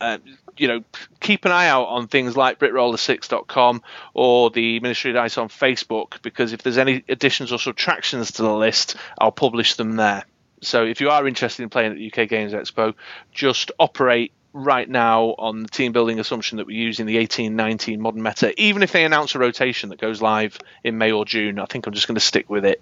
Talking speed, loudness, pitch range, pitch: 220 wpm, -20 LUFS, 110-130 Hz, 120 Hz